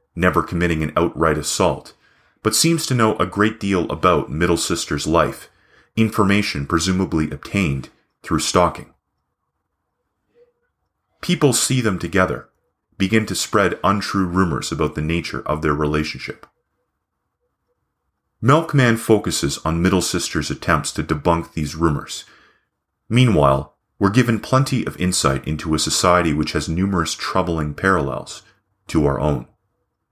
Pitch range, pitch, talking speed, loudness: 80-110 Hz, 90 Hz, 125 wpm, -19 LUFS